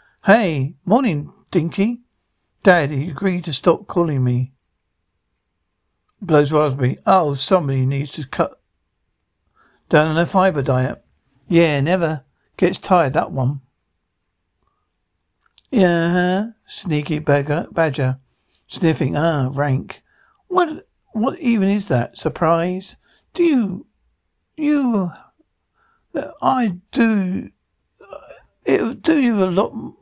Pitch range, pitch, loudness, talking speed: 135-200 Hz, 165 Hz, -19 LUFS, 100 wpm